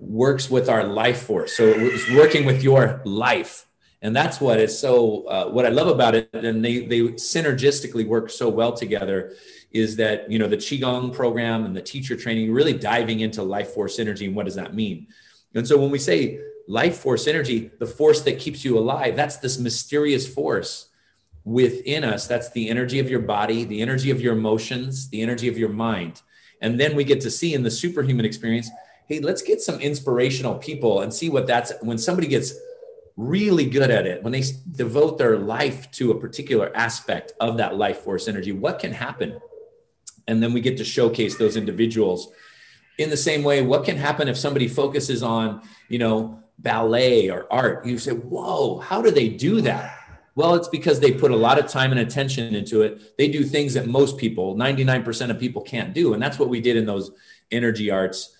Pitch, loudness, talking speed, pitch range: 125 Hz, -21 LUFS, 200 wpm, 115-145 Hz